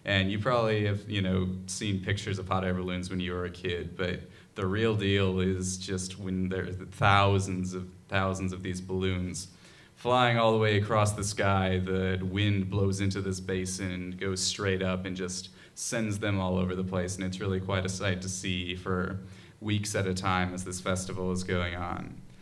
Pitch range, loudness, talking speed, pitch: 90-100 Hz, -30 LUFS, 200 wpm, 95 Hz